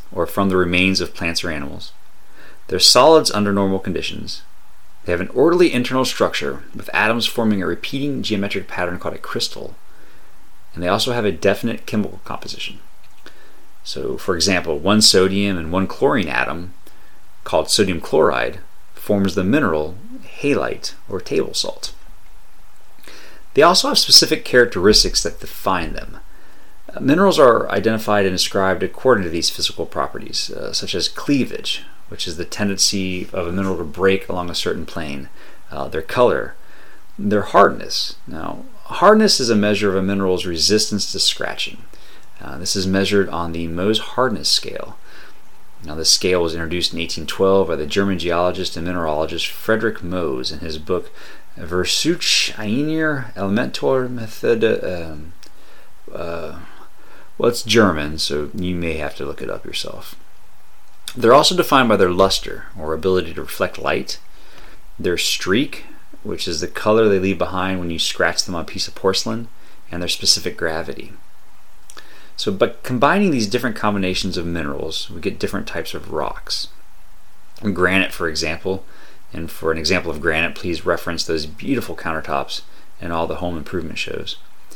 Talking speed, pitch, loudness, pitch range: 155 wpm, 95 Hz, -18 LUFS, 85-105 Hz